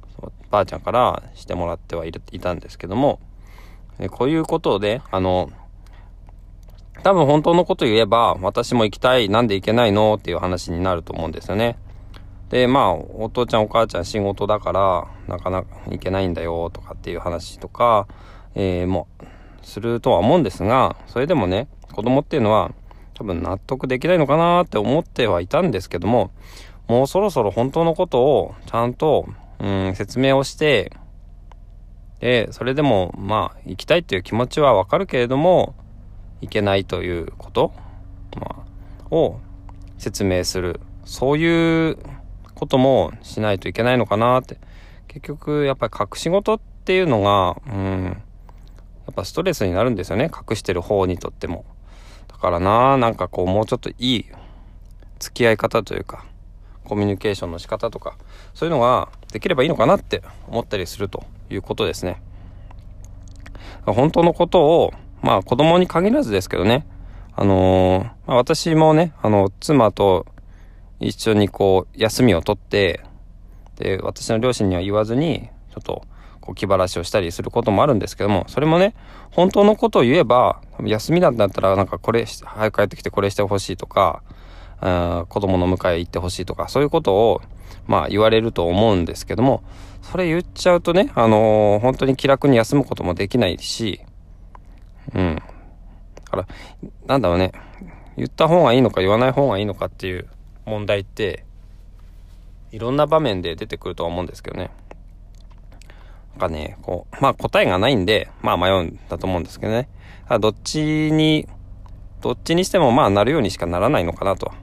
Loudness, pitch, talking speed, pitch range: -19 LUFS, 100 Hz, 350 characters per minute, 90-120 Hz